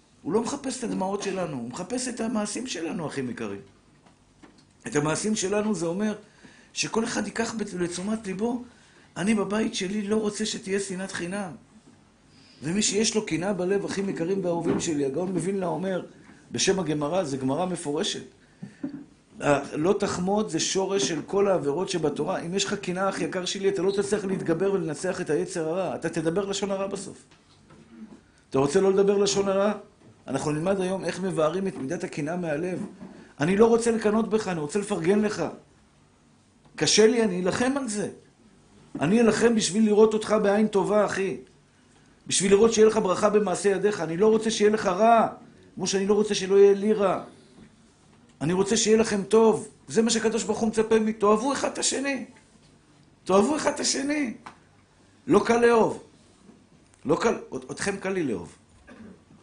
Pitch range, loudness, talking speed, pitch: 180-215 Hz, -25 LUFS, 170 wpm, 200 Hz